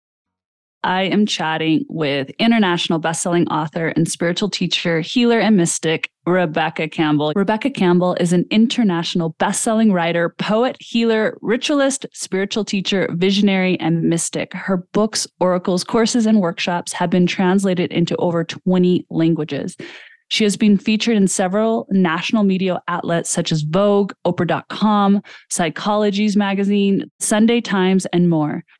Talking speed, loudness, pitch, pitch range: 130 wpm, -18 LUFS, 185 Hz, 170-210 Hz